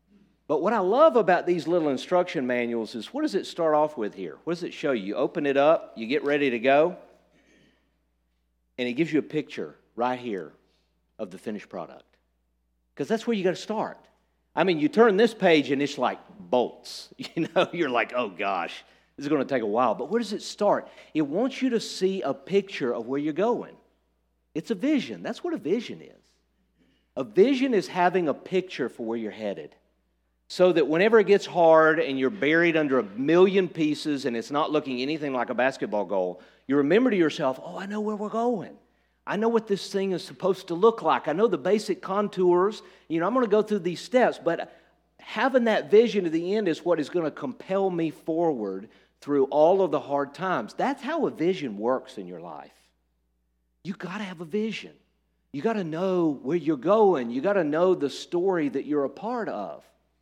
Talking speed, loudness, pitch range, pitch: 210 wpm, -25 LUFS, 135-210 Hz, 170 Hz